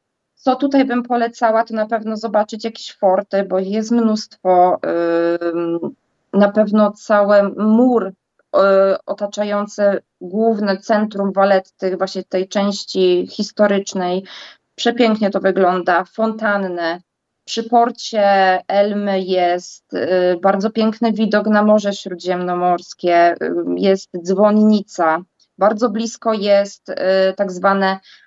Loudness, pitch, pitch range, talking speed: -17 LUFS, 200 Hz, 185-220 Hz, 110 wpm